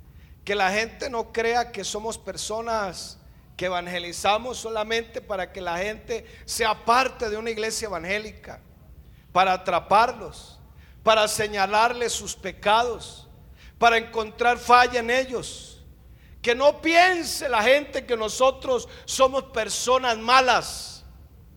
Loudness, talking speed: -23 LUFS, 115 wpm